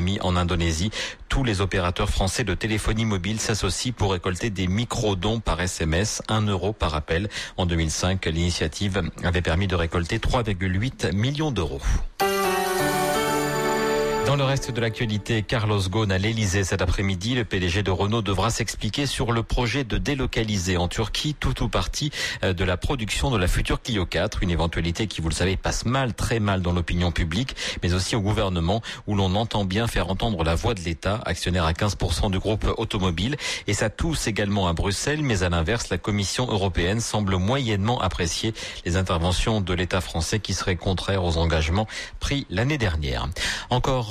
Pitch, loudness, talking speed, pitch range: 100 Hz, -24 LUFS, 175 wpm, 90-115 Hz